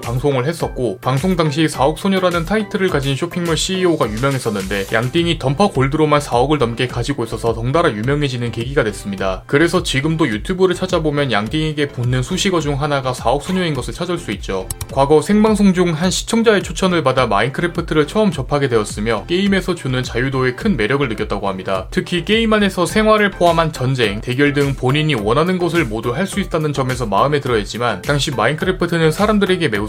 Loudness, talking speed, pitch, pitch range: -17 LUFS, 440 characters per minute, 150 Hz, 125-175 Hz